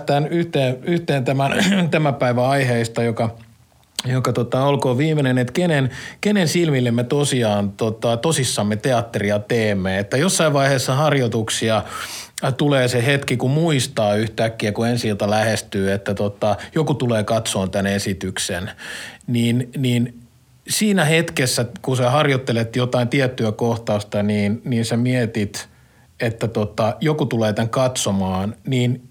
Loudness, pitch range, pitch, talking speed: -19 LUFS, 110-140 Hz, 120 Hz, 130 wpm